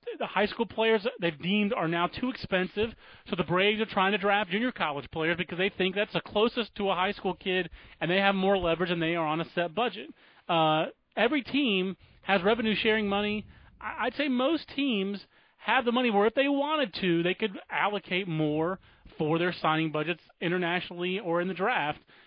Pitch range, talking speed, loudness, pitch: 175-220 Hz, 200 wpm, -28 LUFS, 195 Hz